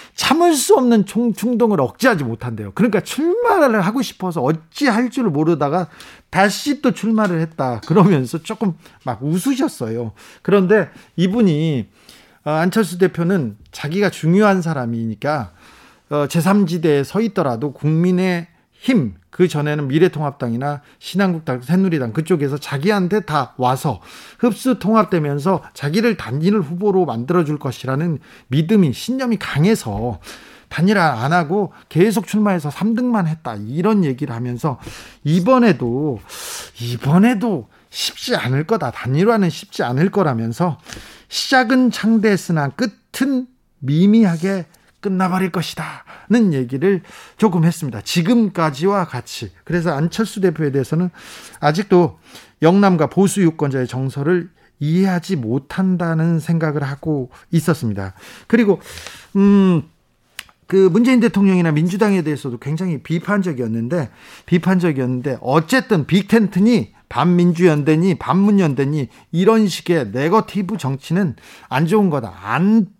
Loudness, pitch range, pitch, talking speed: -17 LUFS, 145-205 Hz, 175 Hz, 300 characters per minute